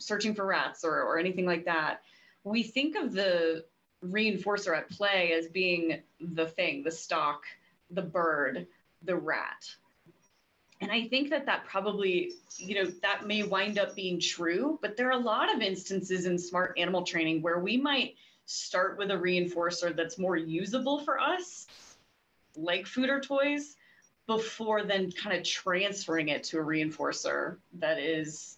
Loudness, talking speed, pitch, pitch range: -31 LUFS, 160 wpm, 185 Hz, 170-210 Hz